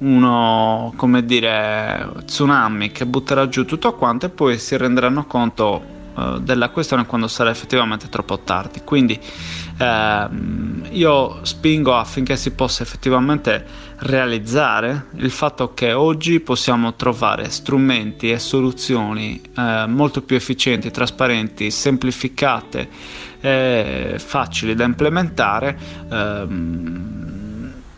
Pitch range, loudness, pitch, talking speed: 110-135 Hz, -18 LUFS, 125 Hz, 110 wpm